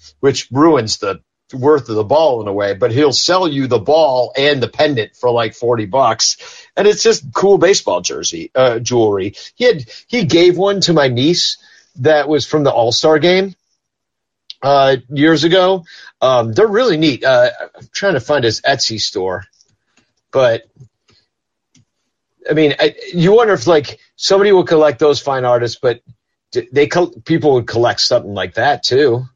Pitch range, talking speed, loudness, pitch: 125-190 Hz, 170 wpm, -13 LUFS, 150 Hz